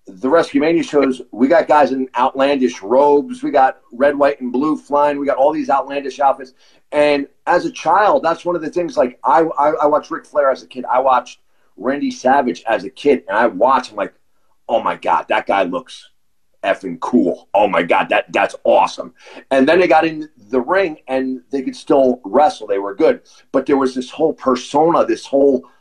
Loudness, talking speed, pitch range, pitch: -16 LUFS, 210 wpm, 130-155 Hz, 140 Hz